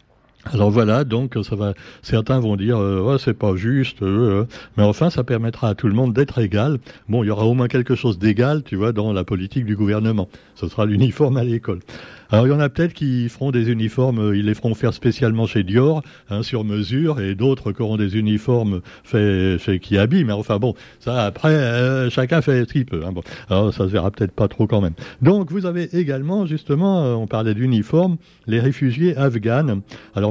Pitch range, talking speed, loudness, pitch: 105-130 Hz, 215 wpm, -19 LUFS, 115 Hz